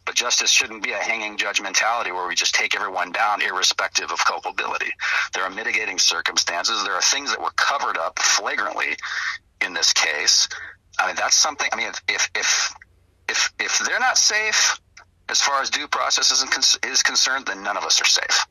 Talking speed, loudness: 185 wpm, -19 LUFS